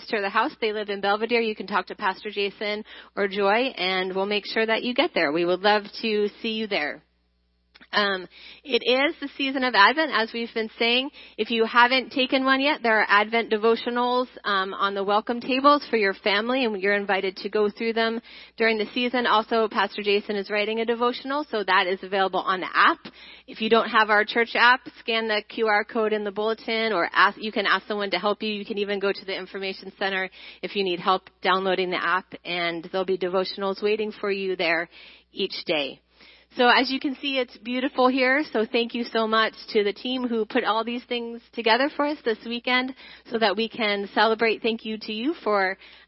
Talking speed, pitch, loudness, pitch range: 215 wpm, 220 Hz, -23 LUFS, 200-245 Hz